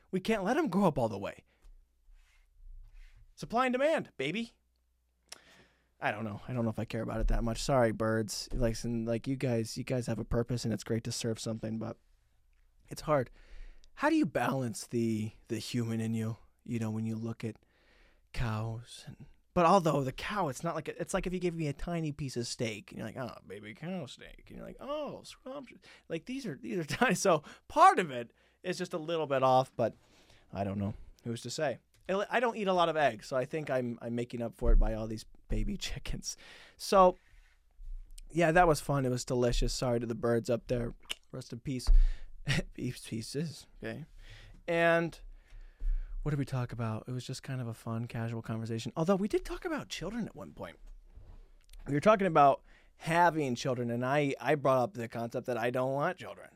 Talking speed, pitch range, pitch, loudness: 215 wpm, 115-160 Hz, 125 Hz, -33 LUFS